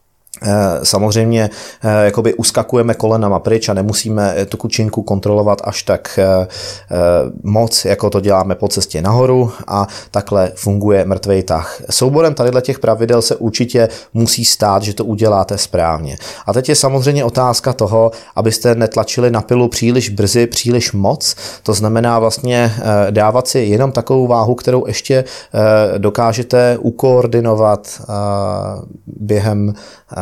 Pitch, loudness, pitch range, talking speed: 110 Hz, -13 LUFS, 100-120 Hz, 125 wpm